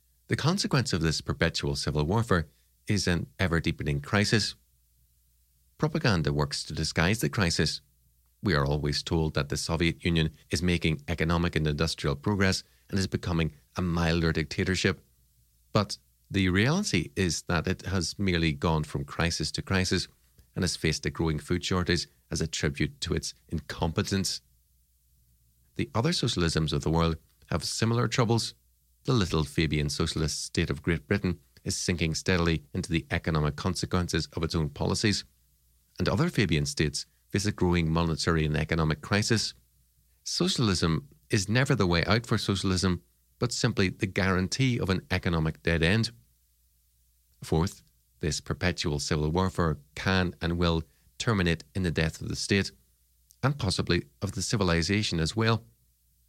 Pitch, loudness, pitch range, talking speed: 85 Hz, -28 LUFS, 75-95 Hz, 150 wpm